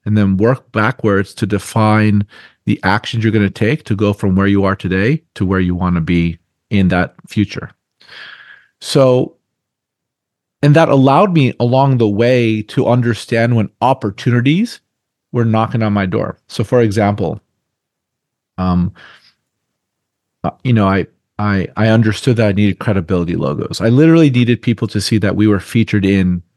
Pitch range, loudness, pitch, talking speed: 100-120 Hz, -14 LUFS, 110 Hz, 160 wpm